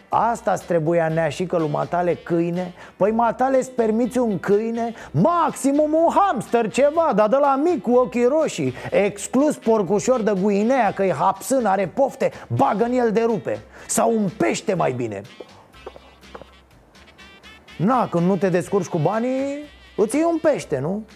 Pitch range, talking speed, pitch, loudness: 190-260 Hz, 155 wpm, 225 Hz, -20 LUFS